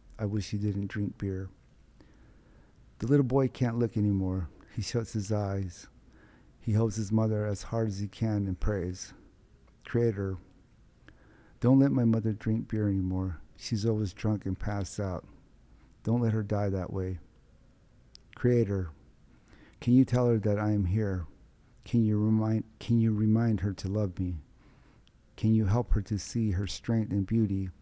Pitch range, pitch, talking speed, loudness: 95-115 Hz, 105 Hz, 165 wpm, -30 LUFS